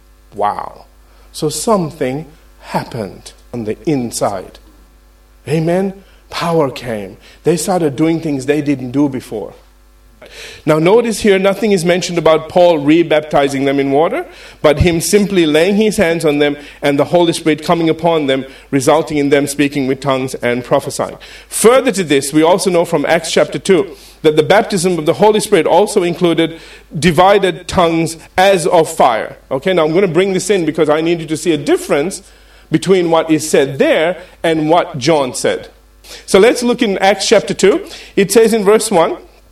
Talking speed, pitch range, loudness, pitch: 175 wpm, 150-190 Hz, -13 LUFS, 165 Hz